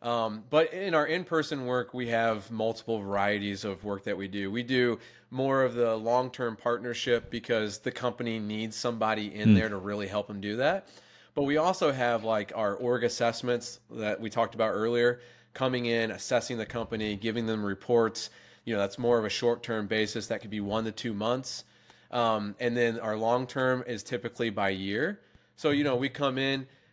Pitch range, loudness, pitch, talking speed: 110-125 Hz, -30 LUFS, 115 Hz, 200 wpm